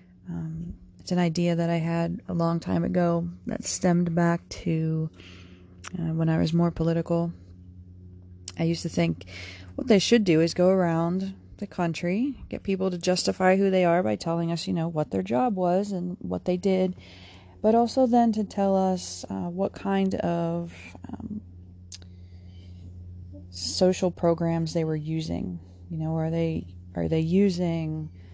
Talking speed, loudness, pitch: 165 wpm, -26 LUFS, 165 Hz